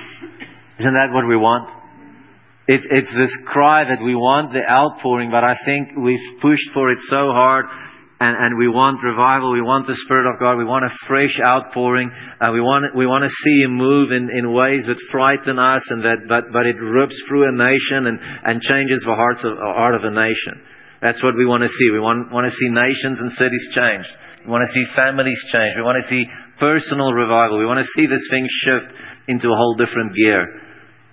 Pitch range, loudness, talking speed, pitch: 120-135 Hz, -16 LUFS, 220 wpm, 125 Hz